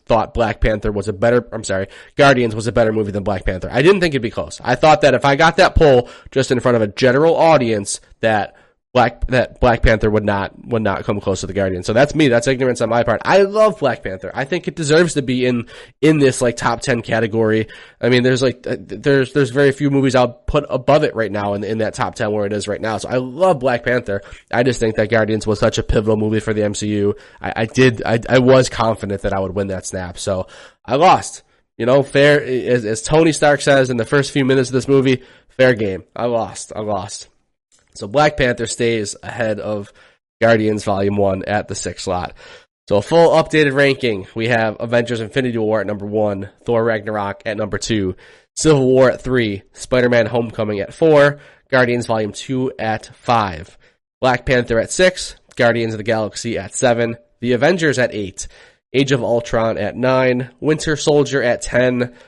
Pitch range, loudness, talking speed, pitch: 105-135 Hz, -16 LUFS, 215 wpm, 120 Hz